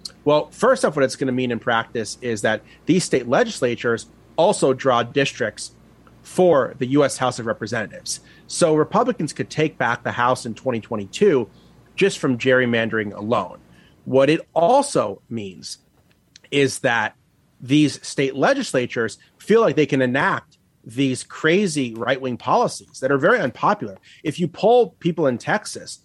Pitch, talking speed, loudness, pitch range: 135 Hz, 150 wpm, -20 LUFS, 120-155 Hz